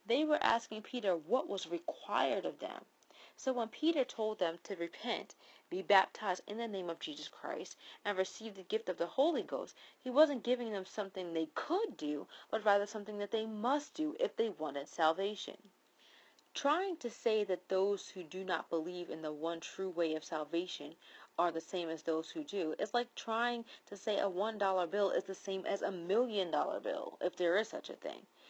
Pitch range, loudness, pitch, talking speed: 175-230 Hz, -37 LUFS, 200 Hz, 200 wpm